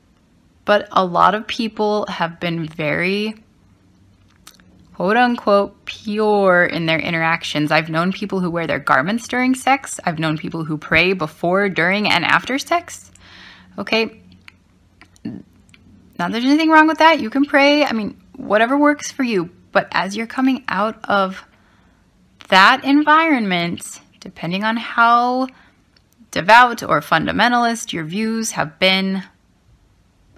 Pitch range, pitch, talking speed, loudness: 160-240 Hz, 200 Hz, 130 wpm, -17 LUFS